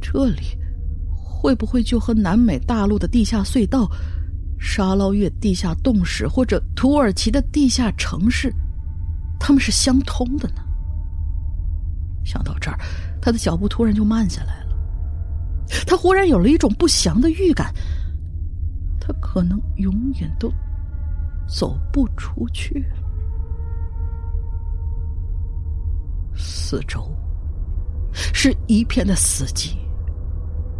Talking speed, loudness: 170 characters per minute, -21 LUFS